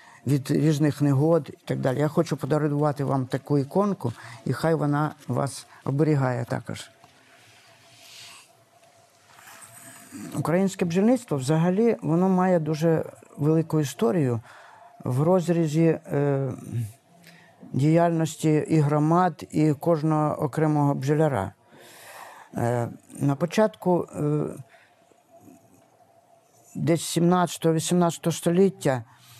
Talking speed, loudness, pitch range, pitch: 90 wpm, -24 LUFS, 140-170 Hz, 155 Hz